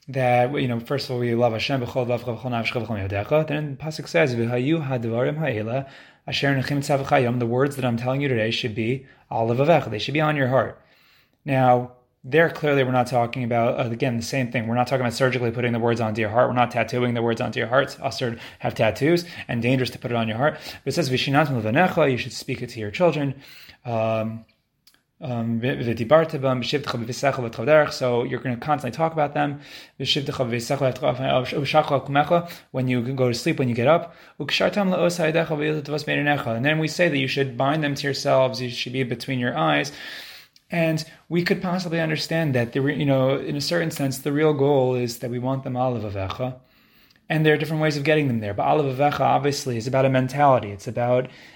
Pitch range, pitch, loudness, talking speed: 120-150 Hz, 130 Hz, -23 LUFS, 185 wpm